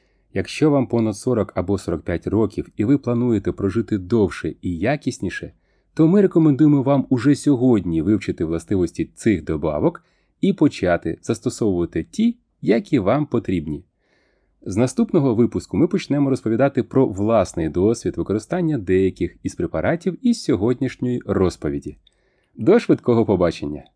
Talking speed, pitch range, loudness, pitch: 125 wpm, 95-140 Hz, -20 LUFS, 115 Hz